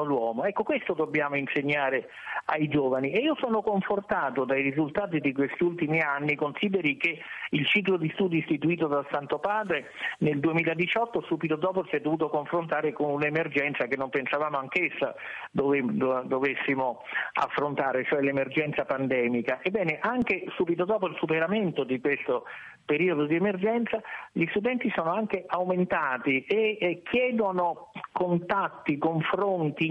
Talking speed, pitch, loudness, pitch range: 140 wpm, 160 Hz, -27 LUFS, 145-185 Hz